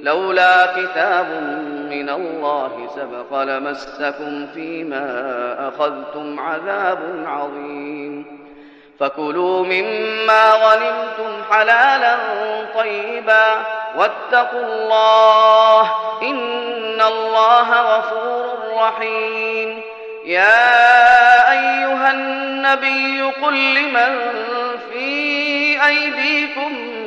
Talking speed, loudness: 60 wpm, -15 LUFS